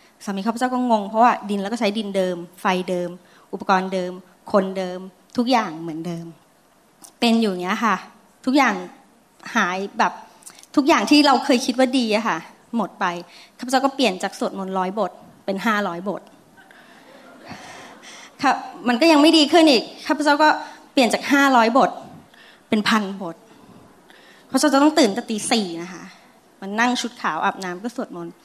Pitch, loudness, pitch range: 220 Hz, -20 LUFS, 185-255 Hz